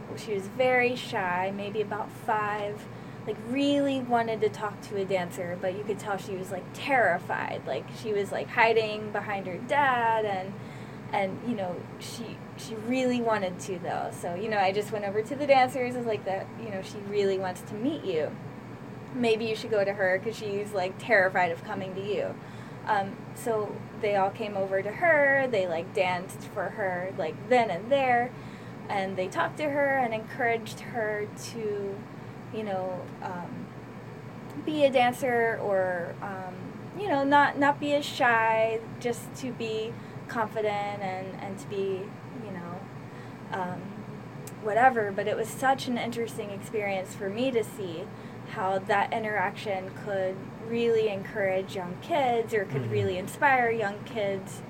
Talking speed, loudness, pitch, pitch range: 170 wpm, -29 LUFS, 210 Hz, 190-235 Hz